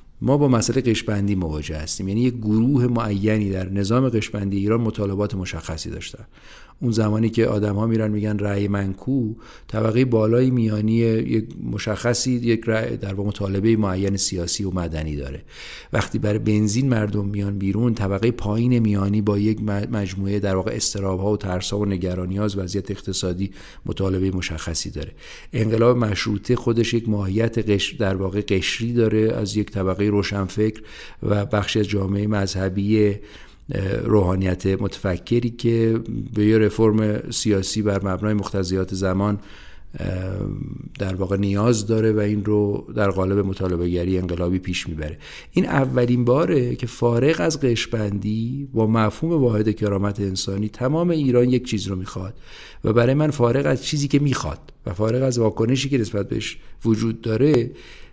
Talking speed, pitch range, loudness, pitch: 150 wpm, 100-115 Hz, -22 LUFS, 105 Hz